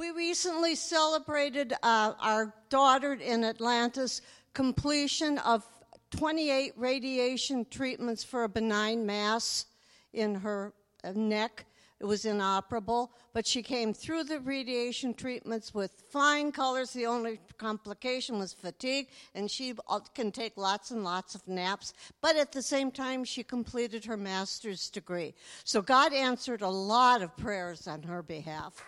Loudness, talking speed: -31 LUFS, 140 wpm